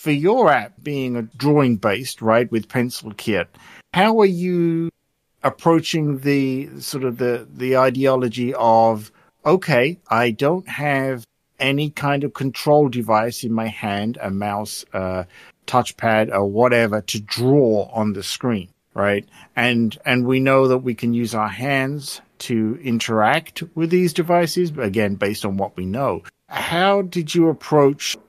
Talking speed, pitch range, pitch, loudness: 150 wpm, 110-145 Hz, 125 Hz, -19 LUFS